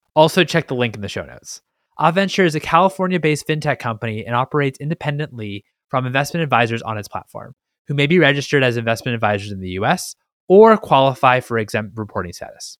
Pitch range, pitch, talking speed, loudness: 115-155 Hz, 135 Hz, 190 wpm, -17 LUFS